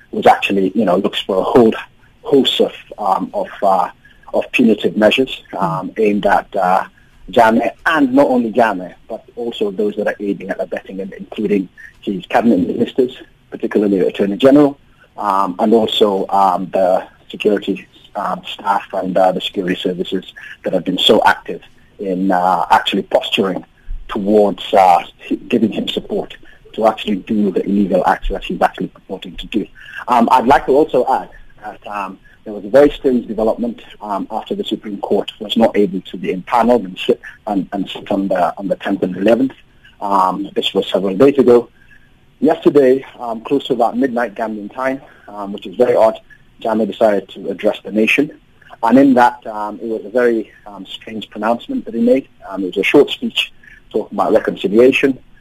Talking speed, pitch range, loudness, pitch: 180 wpm, 105-140 Hz, -15 LUFS, 120 Hz